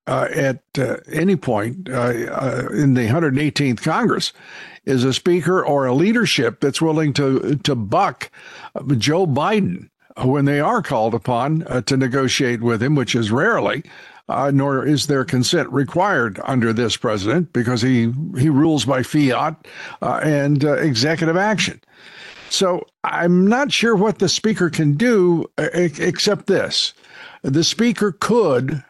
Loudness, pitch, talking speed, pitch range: -18 LUFS, 145 Hz, 145 wpm, 130-170 Hz